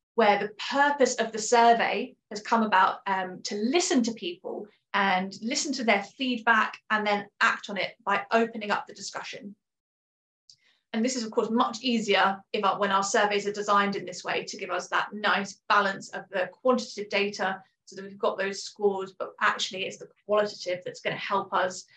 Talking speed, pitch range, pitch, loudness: 195 wpm, 195-235 Hz, 205 Hz, -27 LUFS